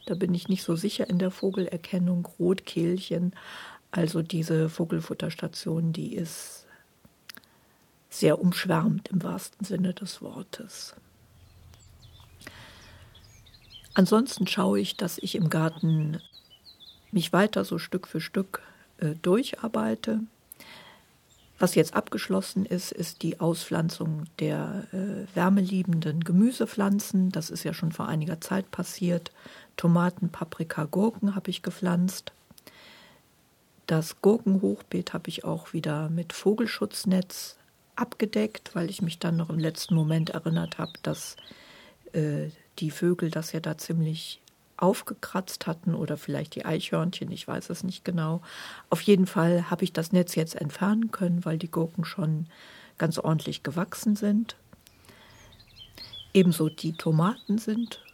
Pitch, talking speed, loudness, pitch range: 175 Hz, 125 wpm, -28 LUFS, 160-190 Hz